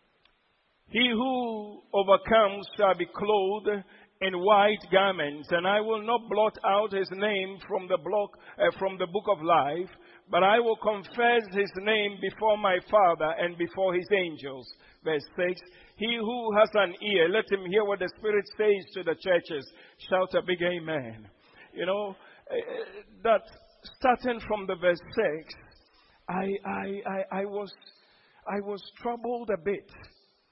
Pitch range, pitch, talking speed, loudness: 180-215 Hz, 200 Hz, 155 wpm, -27 LUFS